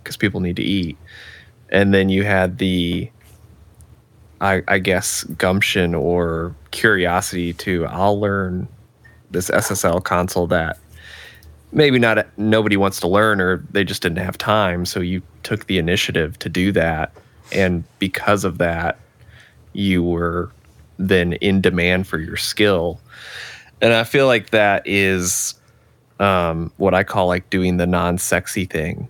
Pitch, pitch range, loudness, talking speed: 95 Hz, 90-100 Hz, -18 LUFS, 145 wpm